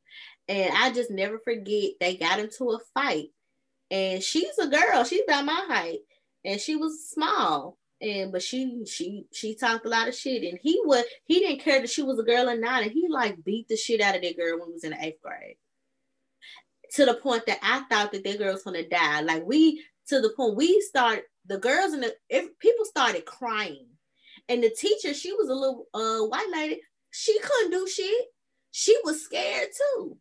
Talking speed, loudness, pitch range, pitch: 215 wpm, -26 LUFS, 205-320 Hz, 250 Hz